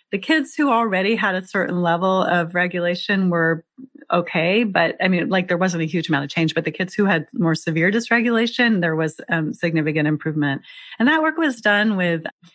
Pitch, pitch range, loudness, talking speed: 180 Hz, 165-215 Hz, -20 LUFS, 200 wpm